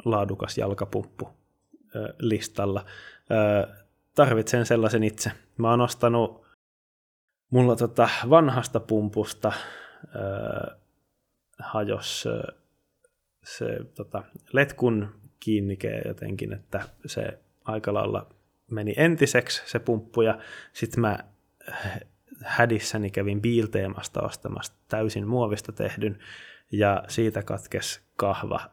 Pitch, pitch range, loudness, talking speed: 110 Hz, 105-120 Hz, -26 LUFS, 85 wpm